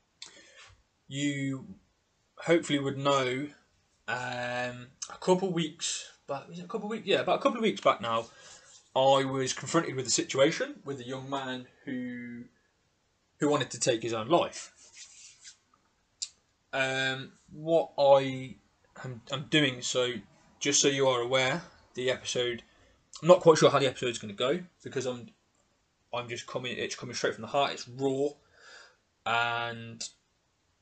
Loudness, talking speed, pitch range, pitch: -29 LUFS, 150 wpm, 120-145 Hz, 135 Hz